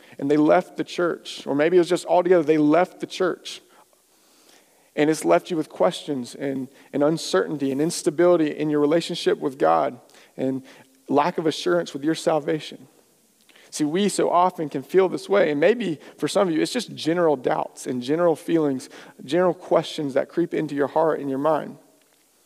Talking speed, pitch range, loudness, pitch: 185 wpm, 145-175 Hz, -22 LUFS, 155 Hz